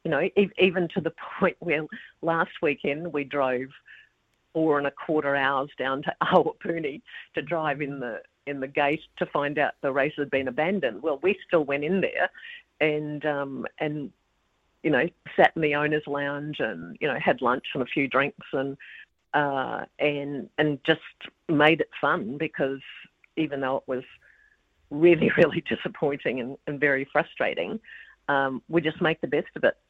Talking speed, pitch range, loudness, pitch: 175 wpm, 140-160 Hz, -26 LUFS, 145 Hz